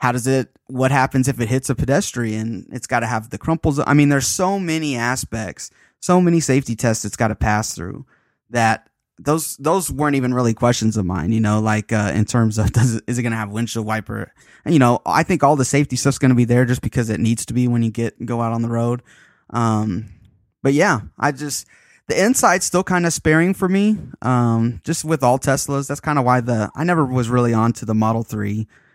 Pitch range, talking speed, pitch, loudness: 115-145 Hz, 235 wpm, 125 Hz, -19 LUFS